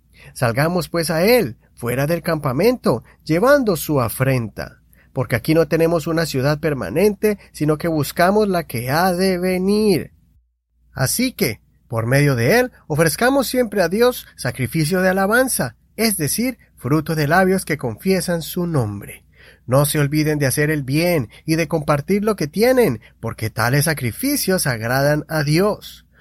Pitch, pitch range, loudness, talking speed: 160 Hz, 130-190 Hz, -18 LUFS, 150 wpm